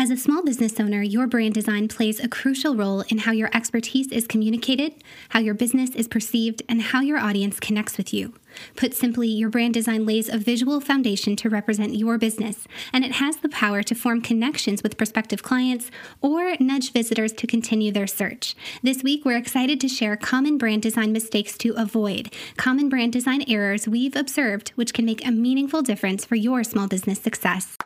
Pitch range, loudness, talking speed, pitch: 220-255 Hz, -22 LUFS, 195 wpm, 230 Hz